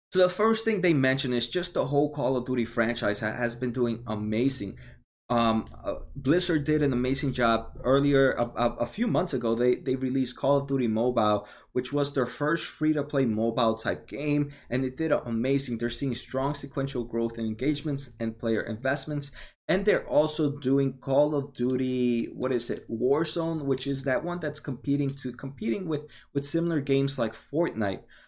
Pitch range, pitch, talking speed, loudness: 120-145 Hz, 130 Hz, 190 wpm, -28 LUFS